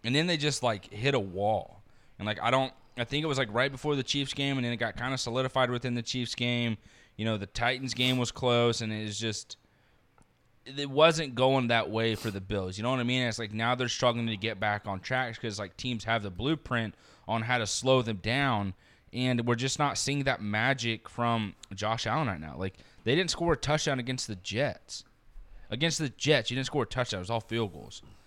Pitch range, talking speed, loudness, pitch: 110-130 Hz, 240 wpm, -30 LUFS, 120 Hz